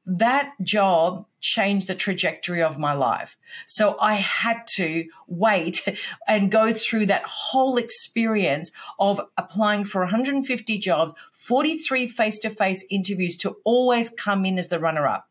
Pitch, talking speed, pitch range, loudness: 205 Hz, 145 wpm, 185-230 Hz, -22 LUFS